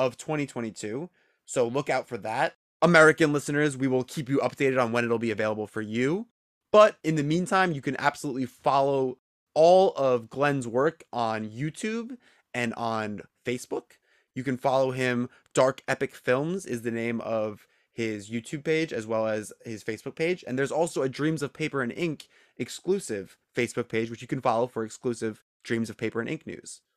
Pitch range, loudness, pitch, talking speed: 115-155 Hz, -27 LUFS, 130 Hz, 180 wpm